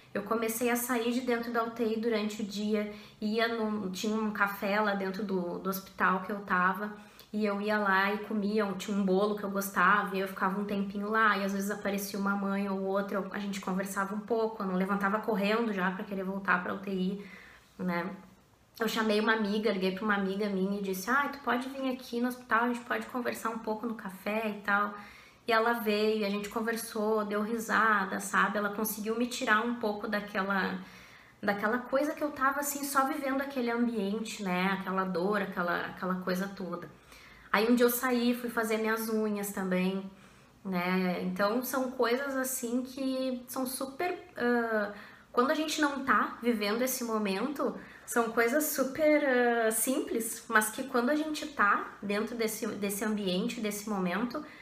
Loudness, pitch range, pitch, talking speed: -31 LUFS, 200-240 Hz, 215 Hz, 190 wpm